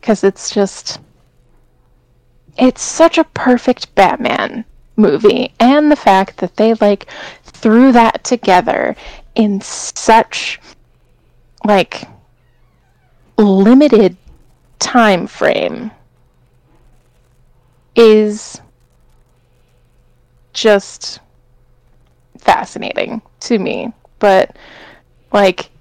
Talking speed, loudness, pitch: 70 wpm, -12 LUFS, 195 Hz